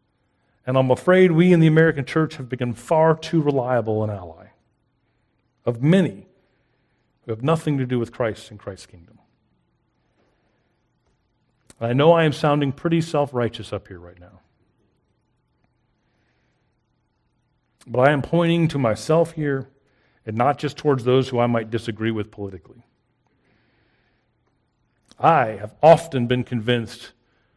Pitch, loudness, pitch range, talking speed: 125 Hz, -20 LUFS, 110-140 Hz, 135 wpm